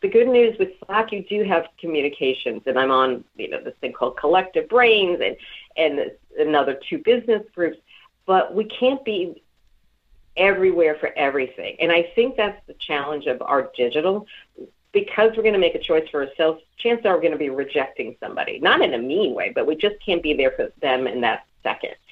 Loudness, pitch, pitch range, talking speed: -21 LUFS, 190 Hz, 150-230 Hz, 200 wpm